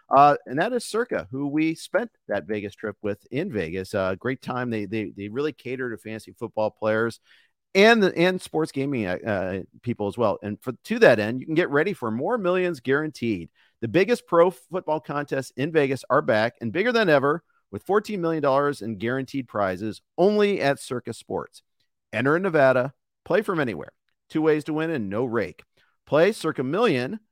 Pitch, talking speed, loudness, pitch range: 135 Hz, 190 wpm, -24 LUFS, 110-160 Hz